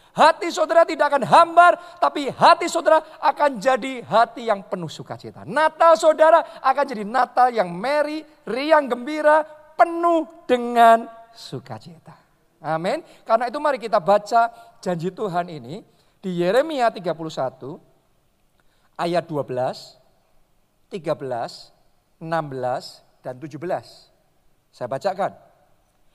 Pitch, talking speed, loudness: 235 Hz, 105 wpm, -20 LUFS